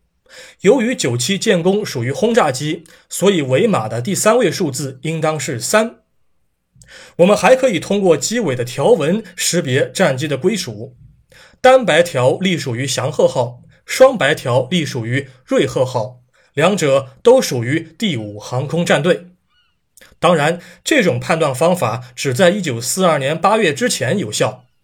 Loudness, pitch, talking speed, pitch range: -16 LUFS, 160 Hz, 225 characters per minute, 130-190 Hz